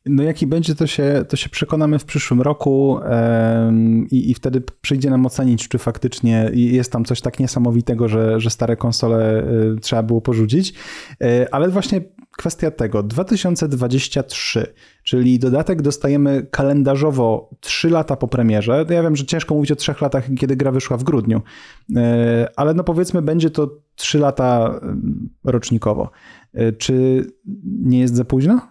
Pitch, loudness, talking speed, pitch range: 130 Hz, -17 LUFS, 160 wpm, 120-150 Hz